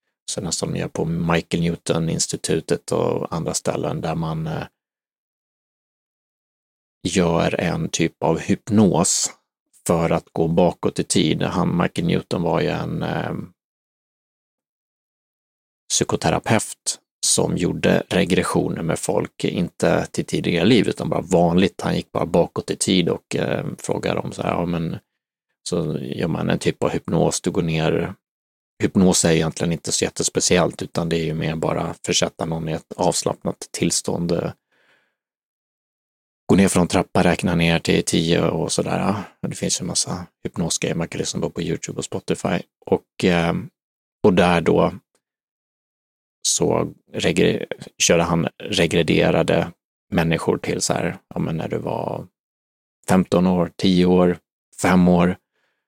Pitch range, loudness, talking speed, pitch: 80-90 Hz, -21 LUFS, 140 wpm, 85 Hz